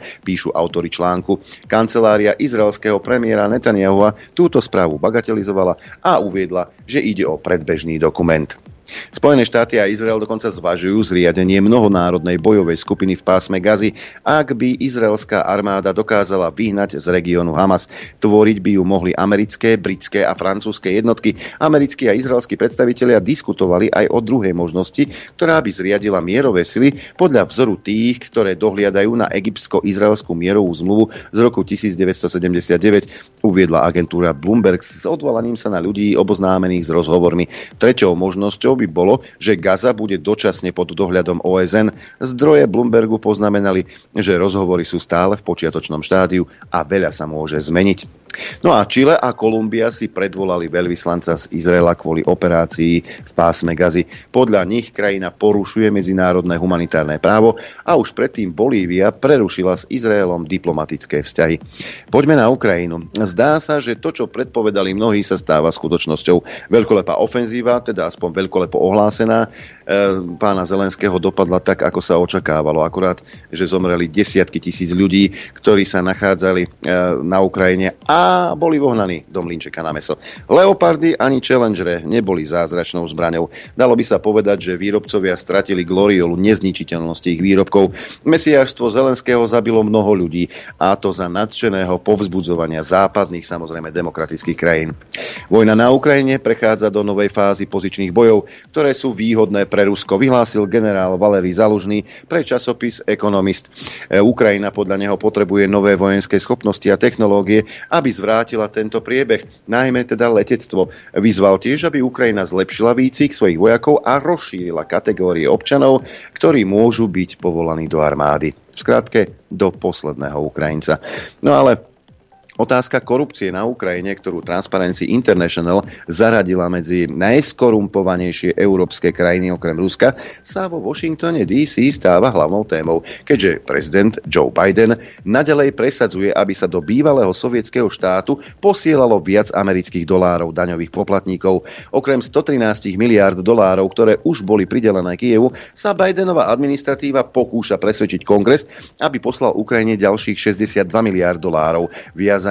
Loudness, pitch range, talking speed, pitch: -15 LUFS, 90-110 Hz, 135 wpm, 100 Hz